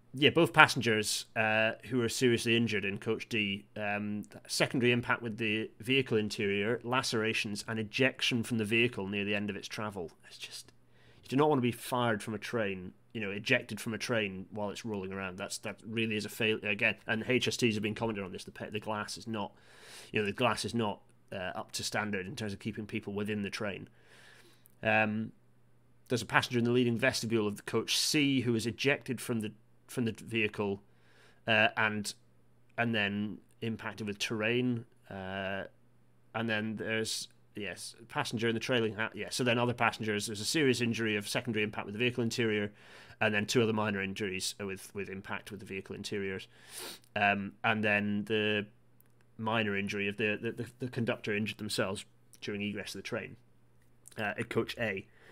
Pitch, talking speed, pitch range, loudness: 110 Hz, 195 wpm, 105-115 Hz, -32 LUFS